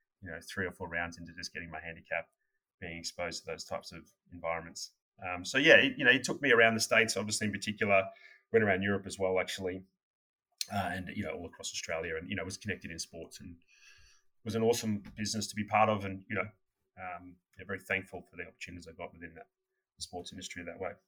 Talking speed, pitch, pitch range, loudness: 230 wpm, 95 Hz, 90-105 Hz, -32 LUFS